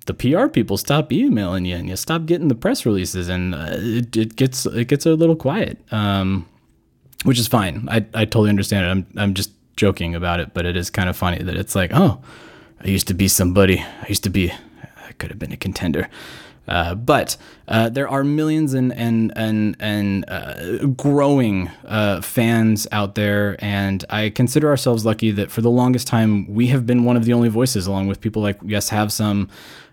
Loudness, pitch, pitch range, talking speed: -19 LUFS, 105 Hz, 95-120 Hz, 210 wpm